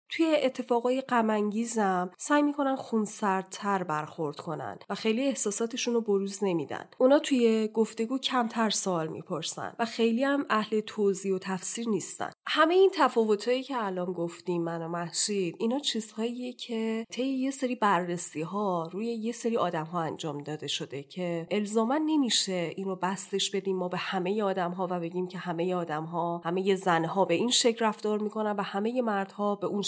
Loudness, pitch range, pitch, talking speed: -28 LUFS, 180-235 Hz, 205 Hz, 165 wpm